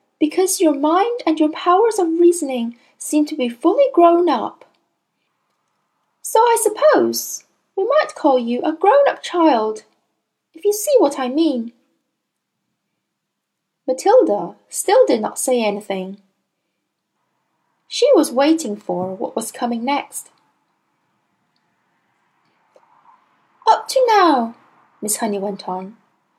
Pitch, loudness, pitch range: 305 Hz, -17 LUFS, 235-380 Hz